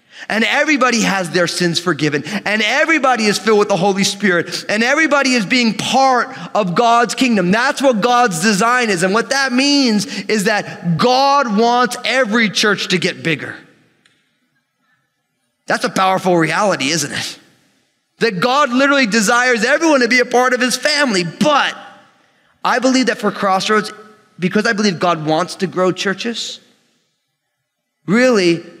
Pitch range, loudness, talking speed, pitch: 190-250 Hz, -14 LUFS, 150 wpm, 220 Hz